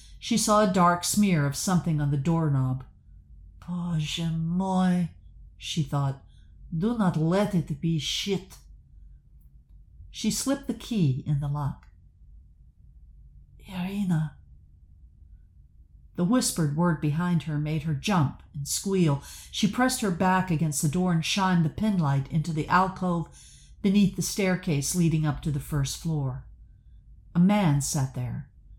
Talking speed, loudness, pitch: 135 wpm, -26 LUFS, 155 Hz